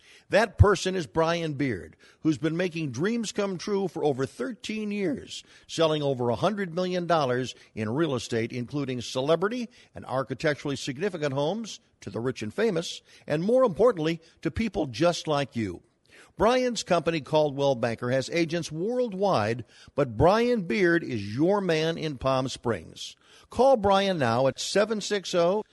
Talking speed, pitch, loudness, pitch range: 145 wpm, 160 Hz, -27 LUFS, 130-195 Hz